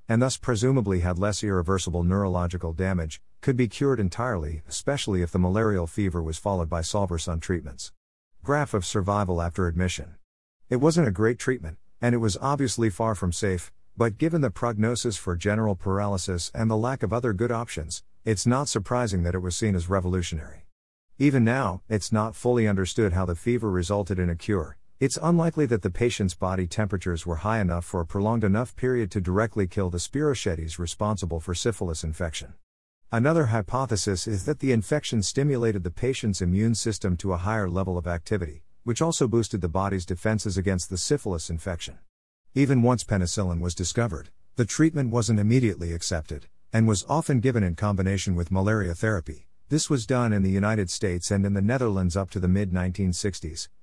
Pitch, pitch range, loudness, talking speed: 100 Hz, 90-115 Hz, -26 LUFS, 180 wpm